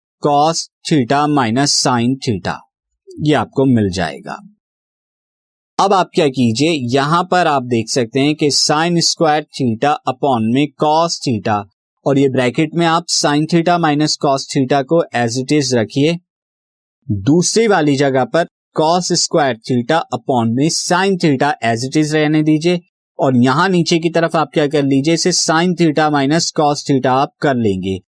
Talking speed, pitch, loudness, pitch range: 160 wpm, 145 Hz, -15 LUFS, 130-165 Hz